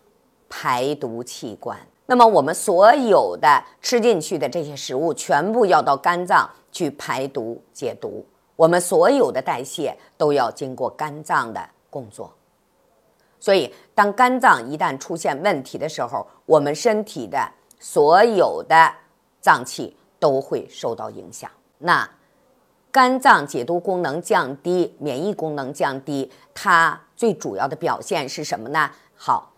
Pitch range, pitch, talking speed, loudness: 155-230 Hz, 175 Hz, 210 characters per minute, -19 LUFS